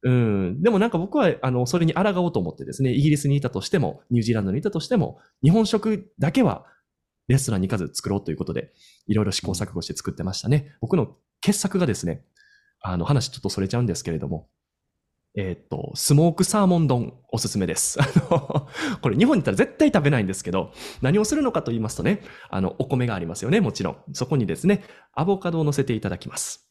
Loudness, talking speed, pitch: -23 LUFS, 460 characters per minute, 130 Hz